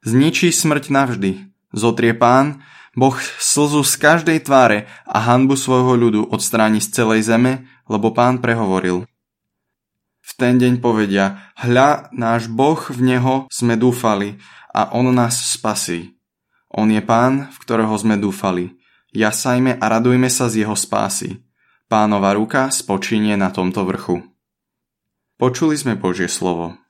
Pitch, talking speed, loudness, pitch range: 115 Hz, 135 wpm, -16 LUFS, 105-130 Hz